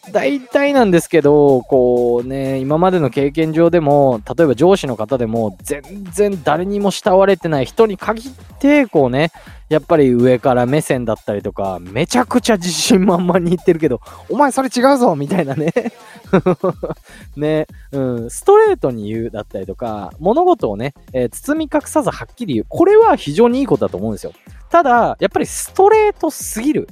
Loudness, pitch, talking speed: -15 LUFS, 175 Hz, 350 characters per minute